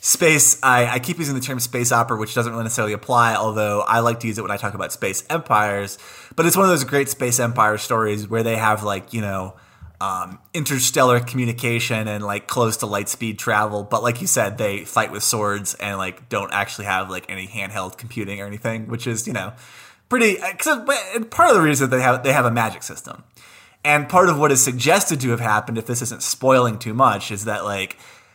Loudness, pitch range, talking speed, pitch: -19 LUFS, 105-130 Hz, 225 wpm, 115 Hz